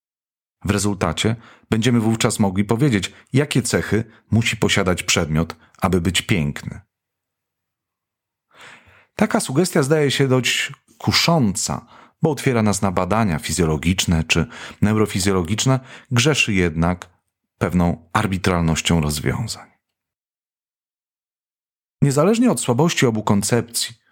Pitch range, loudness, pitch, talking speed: 90-125 Hz, -19 LUFS, 105 Hz, 95 wpm